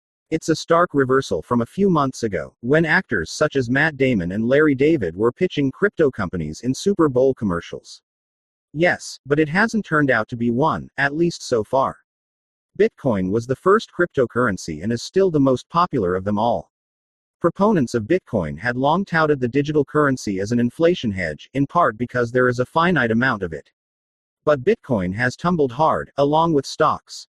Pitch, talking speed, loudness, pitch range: 135 Hz, 185 wpm, -20 LUFS, 110-160 Hz